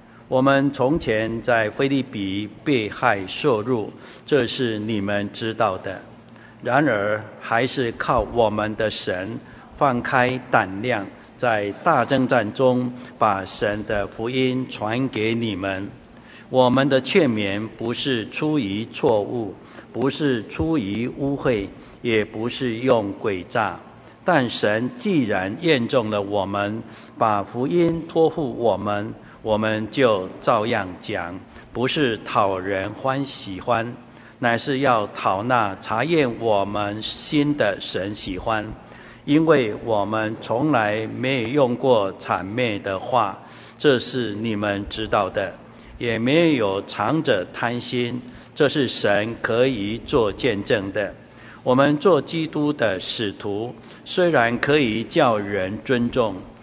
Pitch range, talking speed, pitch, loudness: 105-130 Hz, 175 characters per minute, 115 Hz, -22 LUFS